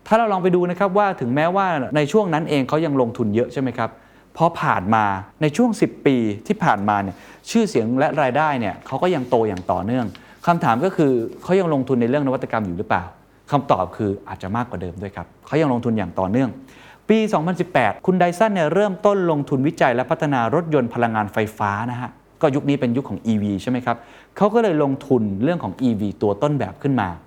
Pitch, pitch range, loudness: 135 Hz, 110-170 Hz, -20 LUFS